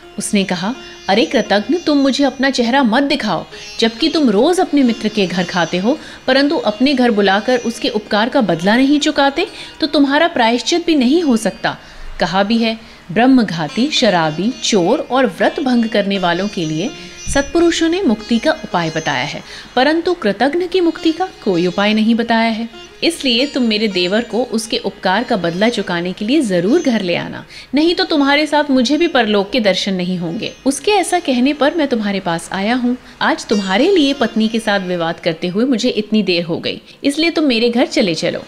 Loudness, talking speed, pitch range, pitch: -15 LUFS, 190 wpm, 200-280 Hz, 240 Hz